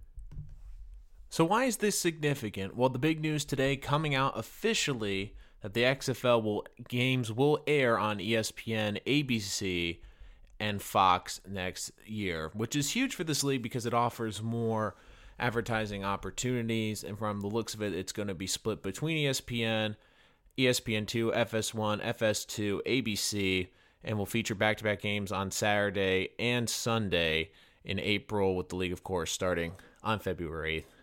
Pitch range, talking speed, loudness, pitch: 95-120 Hz, 145 wpm, -31 LUFS, 110 Hz